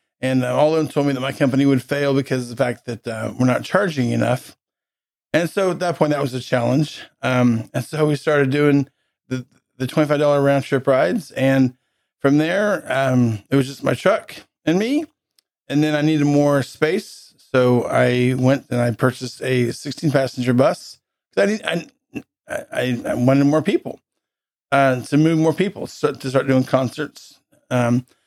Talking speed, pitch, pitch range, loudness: 190 wpm, 135 Hz, 125-150 Hz, -19 LUFS